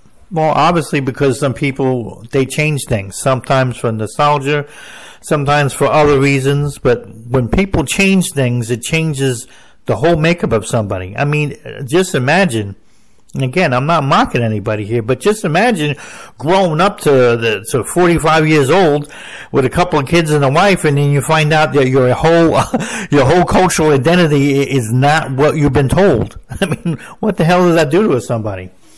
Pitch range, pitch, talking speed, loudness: 130-165 Hz, 145 Hz, 180 wpm, -13 LUFS